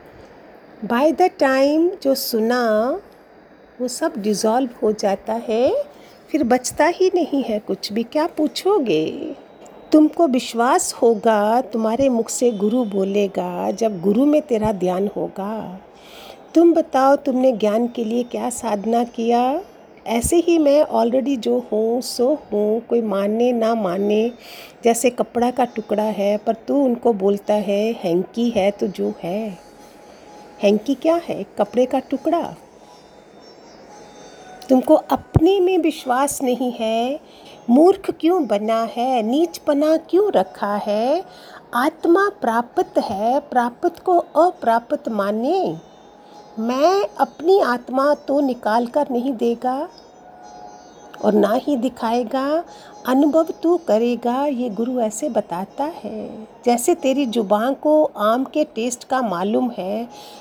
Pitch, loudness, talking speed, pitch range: 245 Hz, -19 LUFS, 125 wpm, 220-290 Hz